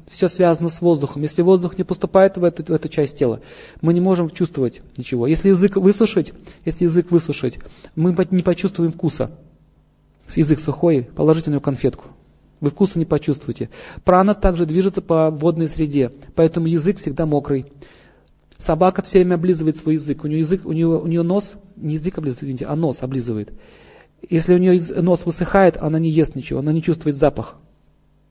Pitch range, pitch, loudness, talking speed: 150-180 Hz, 165 Hz, -18 LUFS, 175 wpm